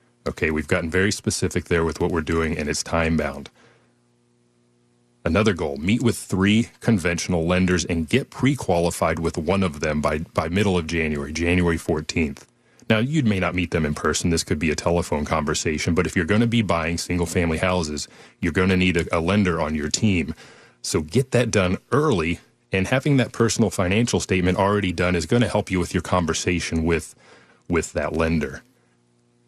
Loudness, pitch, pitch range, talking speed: -22 LUFS, 85 Hz, 80-95 Hz, 190 wpm